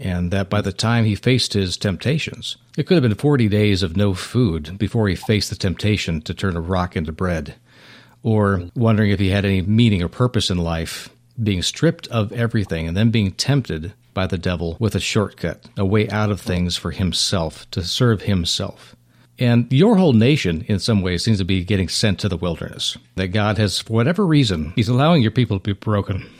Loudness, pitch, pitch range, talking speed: -19 LUFS, 105 Hz, 95-115 Hz, 210 wpm